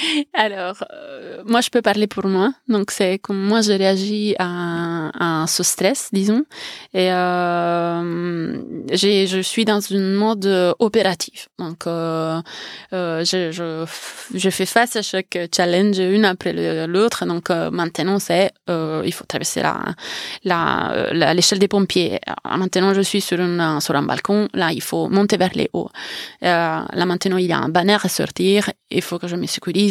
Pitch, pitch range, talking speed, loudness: 185 Hz, 175-205 Hz, 175 wpm, -19 LUFS